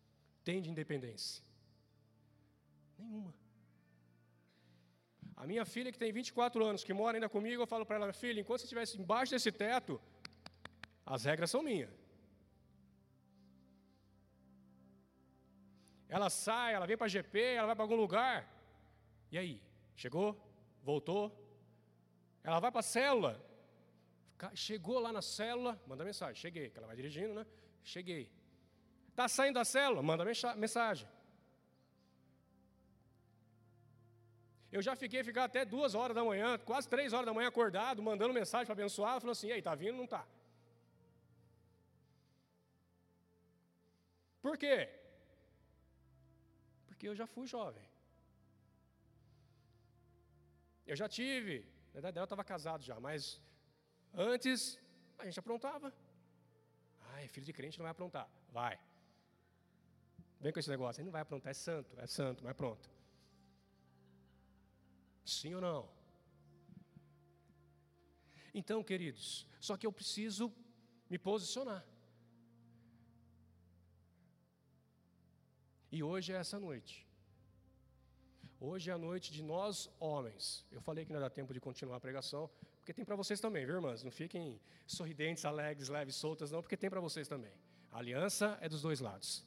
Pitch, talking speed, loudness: 145 Hz, 135 wpm, -40 LUFS